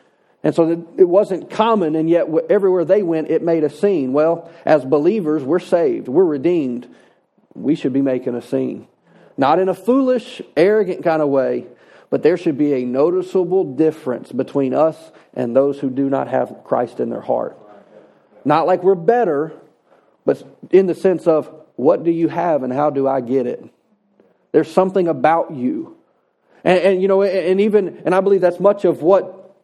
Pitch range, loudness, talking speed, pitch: 150-195 Hz, -17 LUFS, 180 wpm, 170 Hz